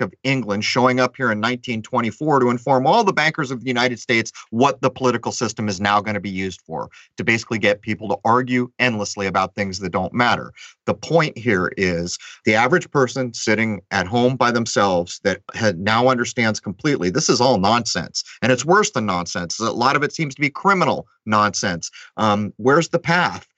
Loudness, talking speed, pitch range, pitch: -19 LUFS, 200 wpm, 105-130 Hz, 120 Hz